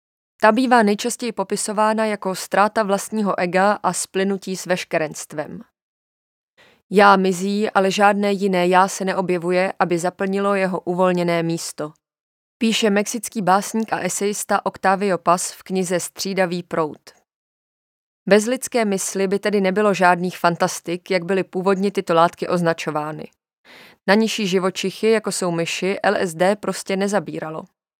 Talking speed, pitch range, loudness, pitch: 125 wpm, 180-205 Hz, -20 LUFS, 190 Hz